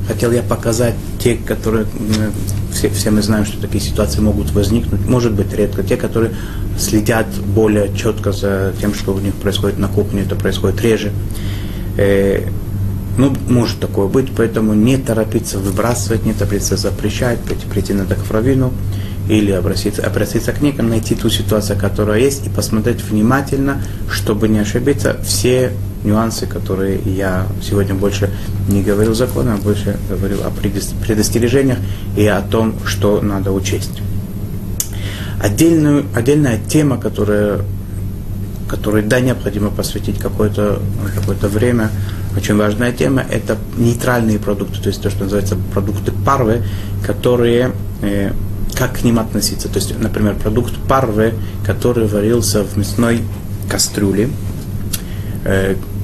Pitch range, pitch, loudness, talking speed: 100-110 Hz, 105 Hz, -16 LUFS, 135 wpm